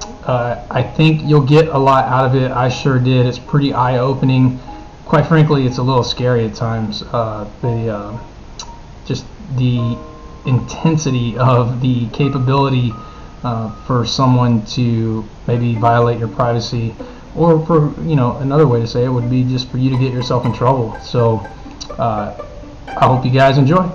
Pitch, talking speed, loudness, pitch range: 125 Hz, 170 wpm, -15 LUFS, 120-135 Hz